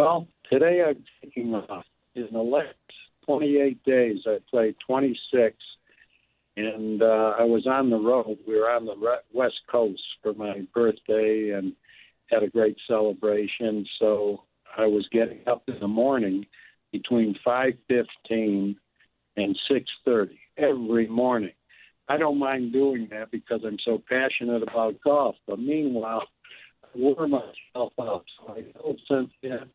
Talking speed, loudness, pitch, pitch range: 150 wpm, -25 LUFS, 115 Hz, 110-130 Hz